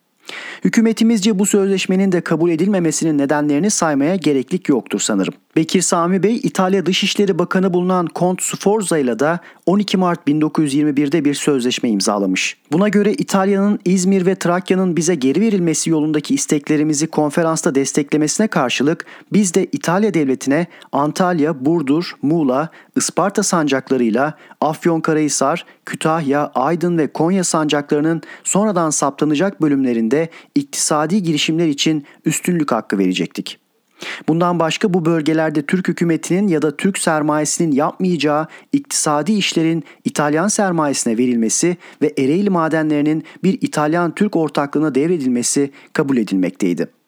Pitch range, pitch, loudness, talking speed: 150-190 Hz, 165 Hz, -17 LUFS, 120 wpm